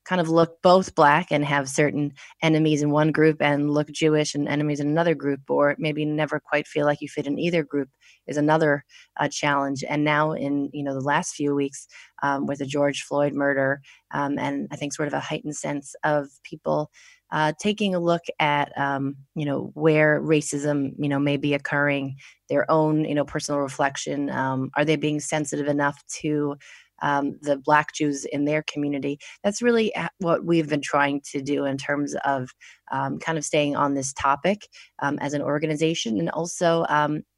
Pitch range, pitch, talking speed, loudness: 140-155 Hz, 145 Hz, 195 wpm, -24 LUFS